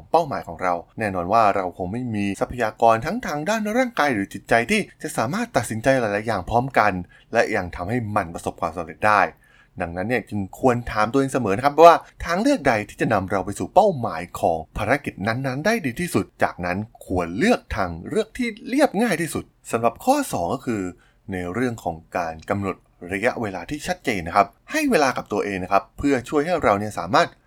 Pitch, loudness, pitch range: 115 Hz, -22 LUFS, 100-150 Hz